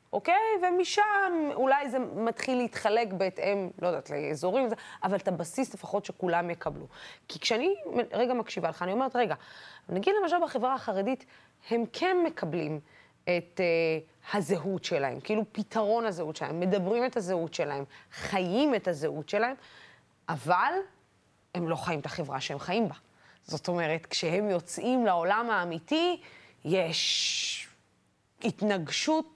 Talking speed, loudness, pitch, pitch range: 135 wpm, -30 LUFS, 205 Hz, 170-255 Hz